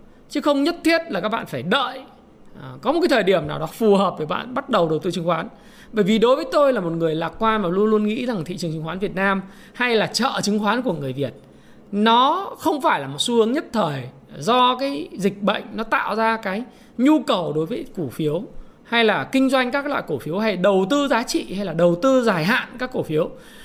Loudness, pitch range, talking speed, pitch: -21 LUFS, 185-255 Hz, 255 wpm, 220 Hz